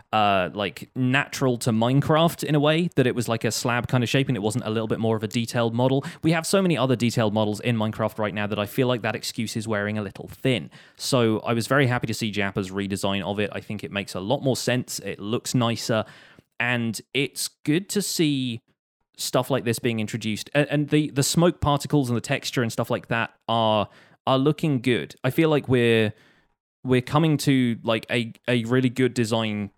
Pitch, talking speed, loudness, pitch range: 120 Hz, 225 wpm, -24 LUFS, 110-135 Hz